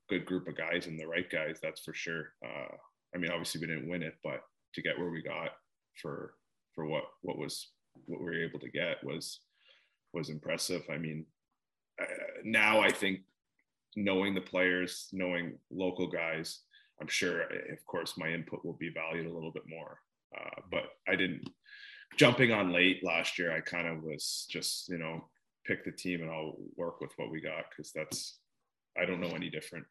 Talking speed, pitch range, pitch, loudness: 195 wpm, 80-90 Hz, 85 Hz, -35 LUFS